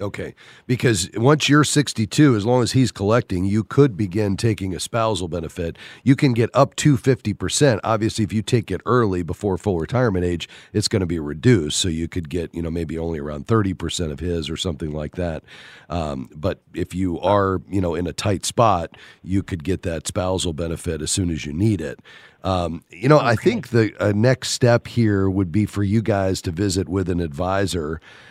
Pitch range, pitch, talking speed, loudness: 85-115 Hz, 100 Hz, 205 wpm, -21 LUFS